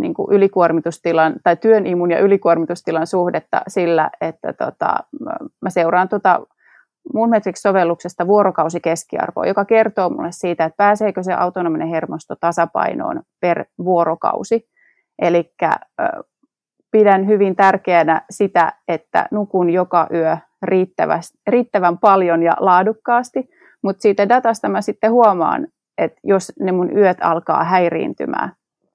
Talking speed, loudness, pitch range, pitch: 115 wpm, -17 LUFS, 170-220 Hz, 190 Hz